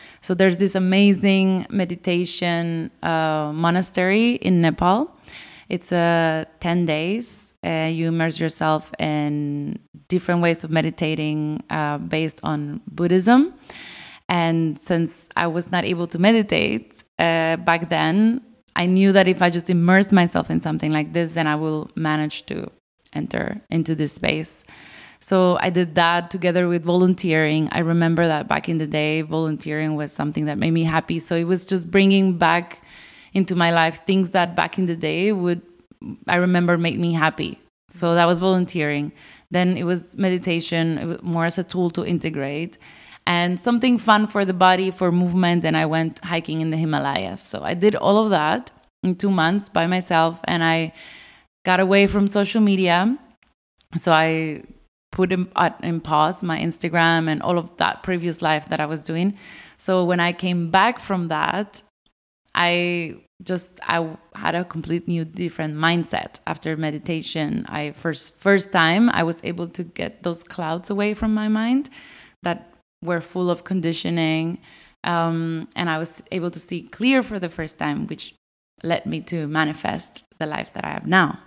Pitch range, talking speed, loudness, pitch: 160-185 Hz, 165 wpm, -21 LUFS, 170 Hz